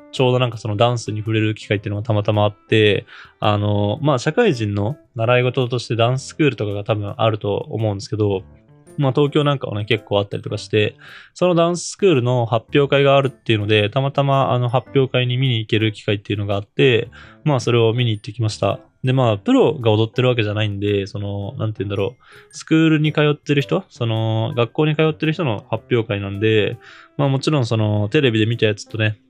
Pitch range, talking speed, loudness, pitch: 105-140 Hz, 455 characters per minute, -19 LUFS, 115 Hz